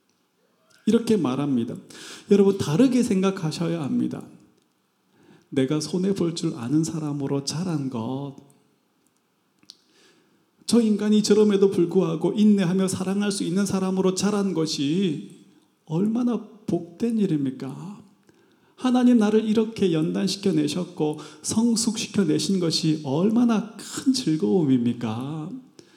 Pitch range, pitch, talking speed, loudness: 155-210 Hz, 190 Hz, 250 characters per minute, -23 LUFS